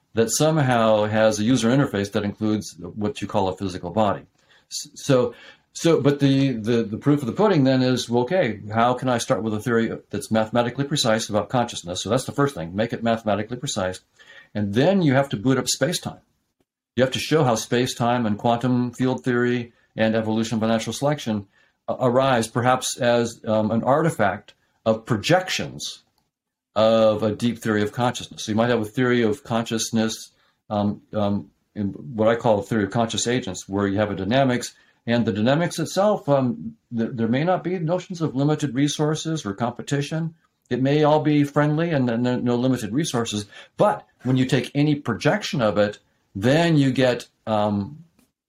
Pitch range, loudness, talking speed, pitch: 110-135 Hz, -22 LUFS, 185 wpm, 120 Hz